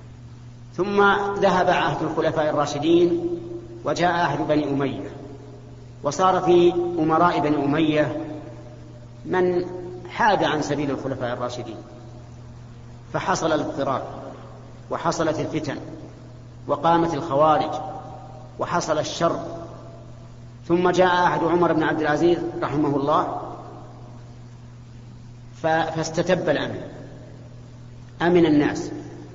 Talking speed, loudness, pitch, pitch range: 85 wpm, -22 LUFS, 145 Hz, 120-165 Hz